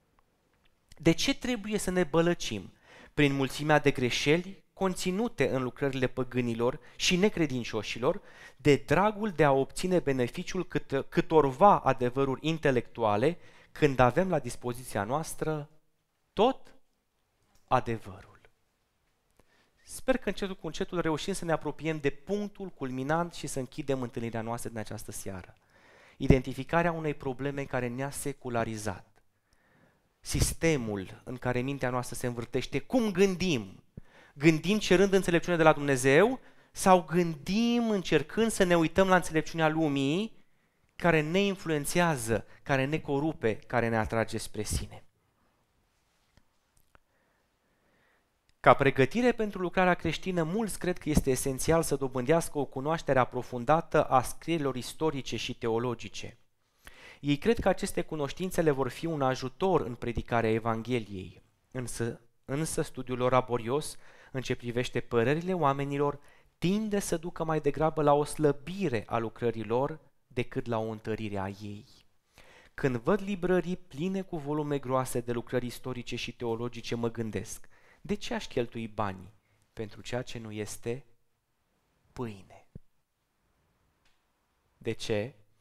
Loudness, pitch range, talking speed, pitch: -30 LUFS, 120-165 Hz, 125 wpm, 140 Hz